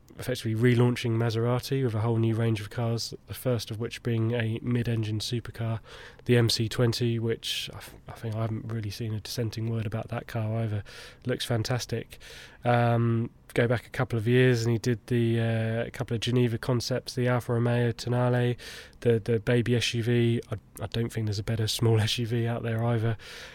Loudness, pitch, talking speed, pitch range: -28 LUFS, 115 Hz, 190 wpm, 115-120 Hz